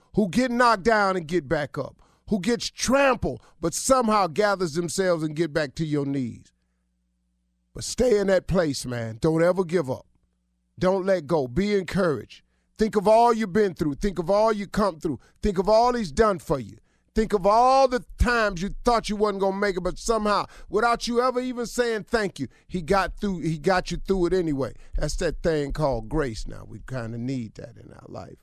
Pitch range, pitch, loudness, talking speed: 145-215 Hz, 185 Hz, -24 LUFS, 210 wpm